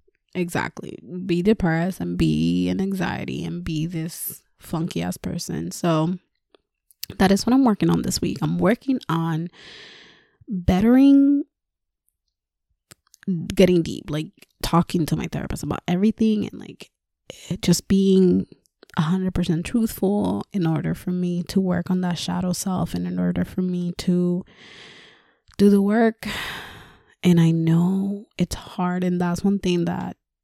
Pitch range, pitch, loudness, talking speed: 165-195 Hz, 180 Hz, -22 LUFS, 145 wpm